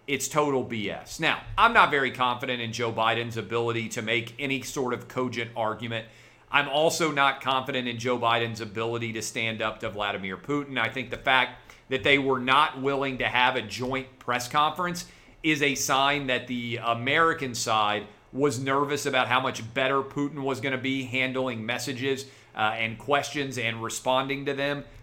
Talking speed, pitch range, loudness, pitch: 180 wpm, 115-140 Hz, -26 LUFS, 125 Hz